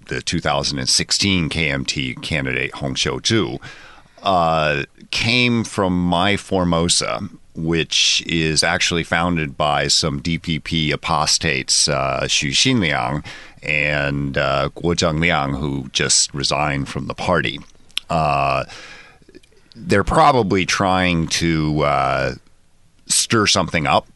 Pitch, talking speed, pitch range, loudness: 80 Hz, 100 wpm, 75-90 Hz, -18 LUFS